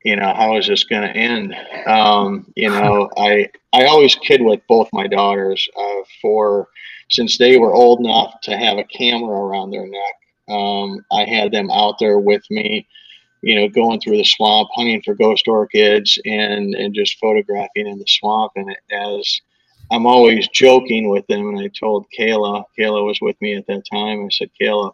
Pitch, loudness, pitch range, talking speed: 105 Hz, -15 LUFS, 100-115 Hz, 190 wpm